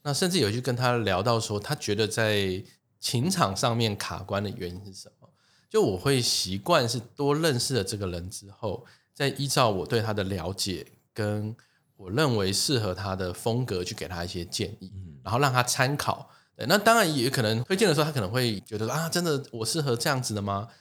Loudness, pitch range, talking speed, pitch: -27 LUFS, 100-135 Hz, 290 characters per minute, 115 Hz